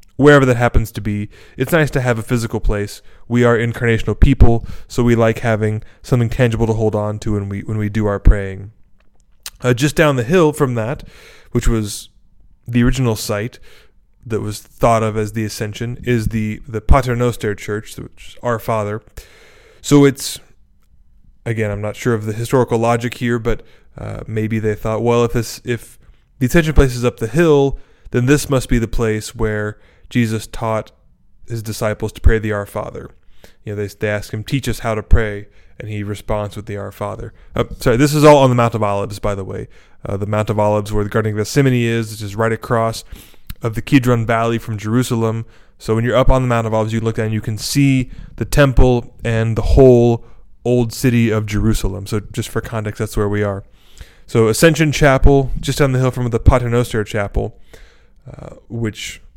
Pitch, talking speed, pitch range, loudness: 115 Hz, 205 wpm, 105-120 Hz, -17 LUFS